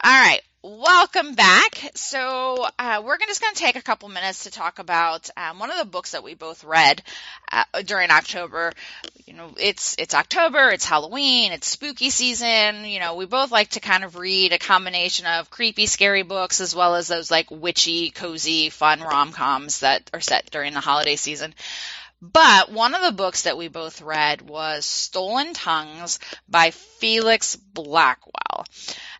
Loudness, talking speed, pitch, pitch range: -19 LUFS, 175 wpm, 185 Hz, 165-230 Hz